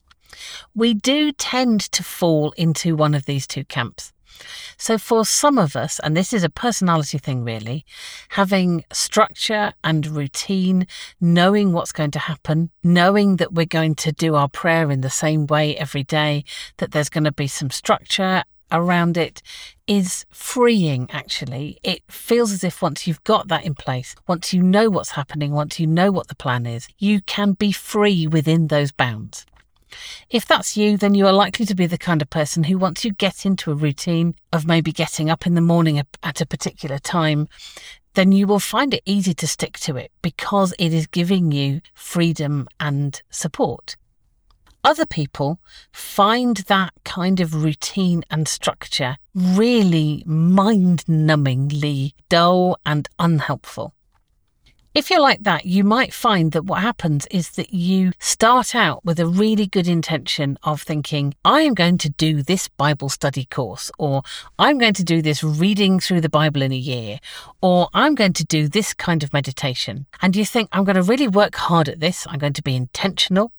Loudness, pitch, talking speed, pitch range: -19 LUFS, 170 Hz, 180 wpm, 150-195 Hz